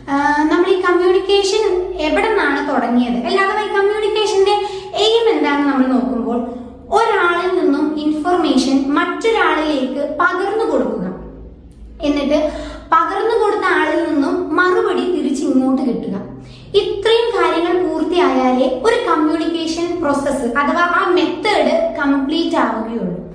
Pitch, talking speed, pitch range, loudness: 330 Hz, 95 wpm, 285-380 Hz, -16 LUFS